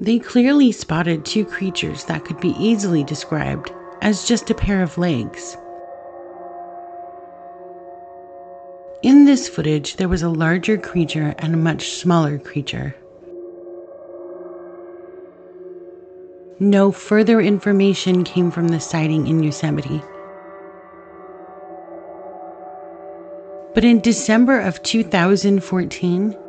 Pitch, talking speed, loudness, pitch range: 180 Hz, 95 wpm, -18 LUFS, 175-195 Hz